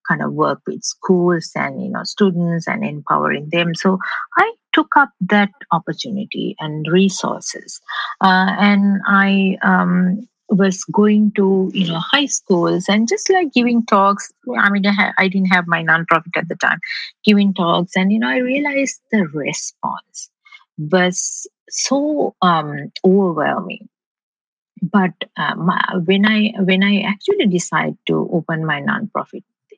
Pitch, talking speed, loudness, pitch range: 195 Hz, 150 wpm, -17 LUFS, 180-215 Hz